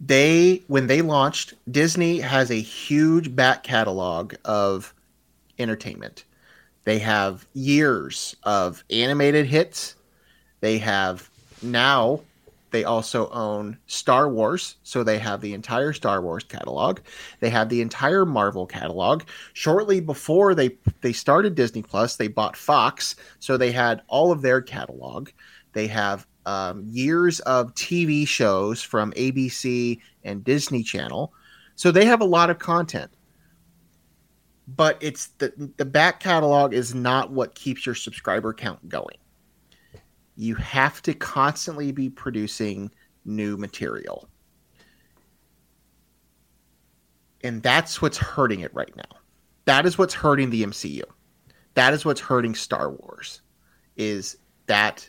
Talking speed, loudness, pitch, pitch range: 130 wpm, -22 LUFS, 125 Hz, 105-145 Hz